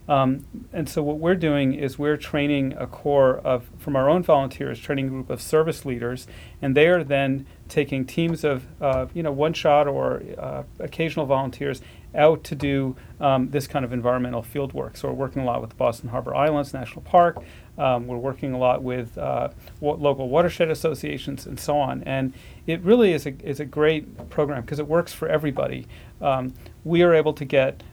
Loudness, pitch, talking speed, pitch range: -23 LUFS, 140 Hz, 200 wpm, 130-155 Hz